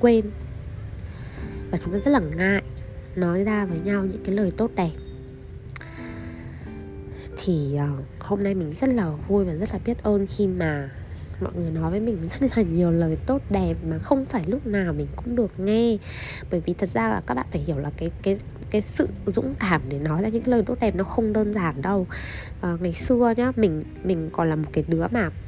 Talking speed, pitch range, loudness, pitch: 215 wpm, 155-210 Hz, -24 LUFS, 185 Hz